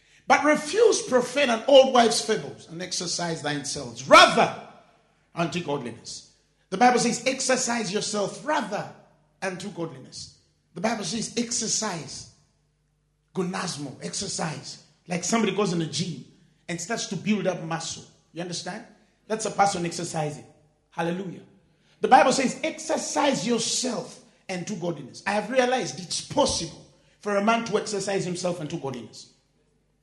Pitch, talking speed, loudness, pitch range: 190 Hz, 135 wpm, -24 LUFS, 165-230 Hz